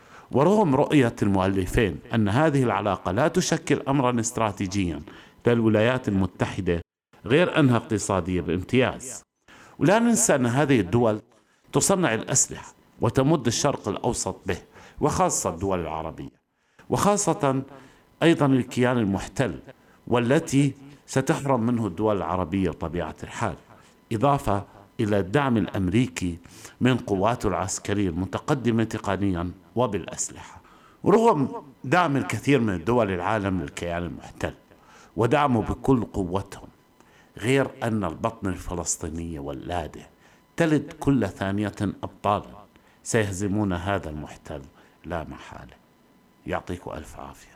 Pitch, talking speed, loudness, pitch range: 110 Hz, 100 wpm, -24 LUFS, 95-135 Hz